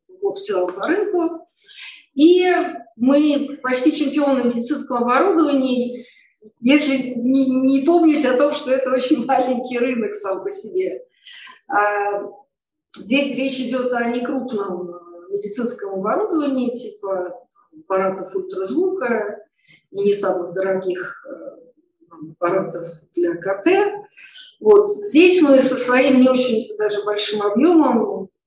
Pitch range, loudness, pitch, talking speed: 205-310 Hz, -18 LUFS, 255 Hz, 110 wpm